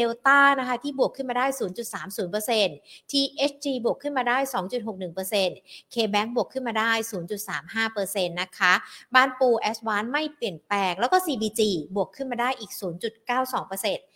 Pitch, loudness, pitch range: 225 Hz, -25 LUFS, 195-255 Hz